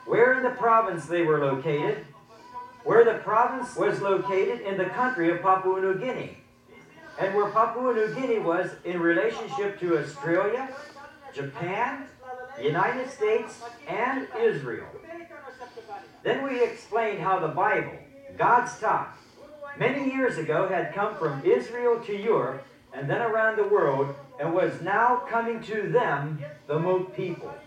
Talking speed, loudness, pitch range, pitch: 140 wpm, -26 LUFS, 185-260 Hz, 225 Hz